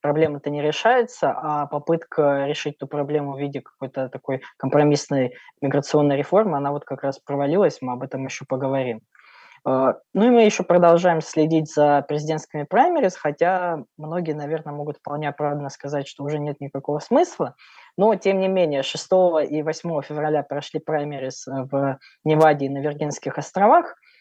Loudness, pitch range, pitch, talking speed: -22 LUFS, 140-160 Hz, 145 Hz, 155 wpm